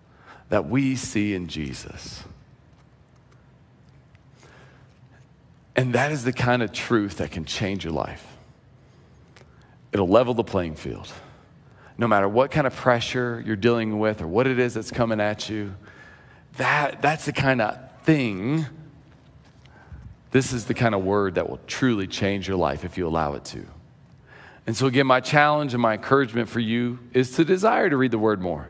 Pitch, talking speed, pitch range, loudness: 120 Hz, 165 wpm, 105-130 Hz, -23 LUFS